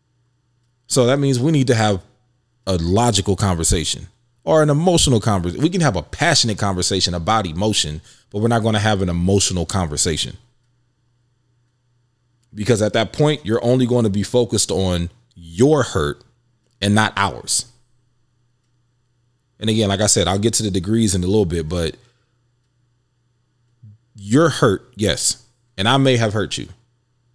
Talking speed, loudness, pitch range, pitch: 155 wpm, -18 LUFS, 100-125 Hz, 120 Hz